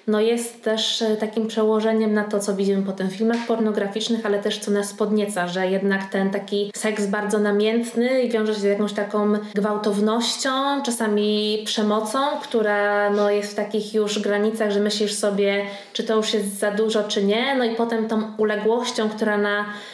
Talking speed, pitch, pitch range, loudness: 175 wpm, 215 Hz, 205-220 Hz, -22 LUFS